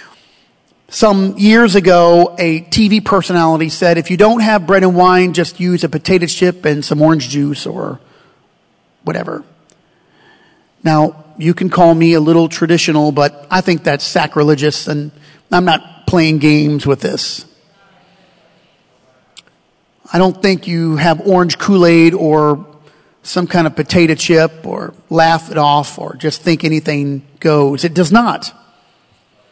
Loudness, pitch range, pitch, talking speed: -12 LUFS, 155-180 Hz, 165 Hz, 140 wpm